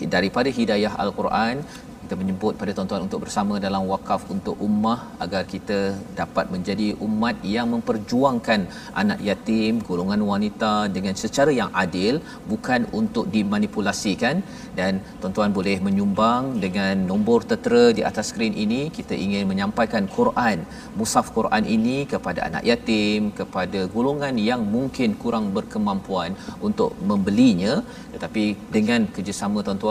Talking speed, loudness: 130 wpm, -23 LUFS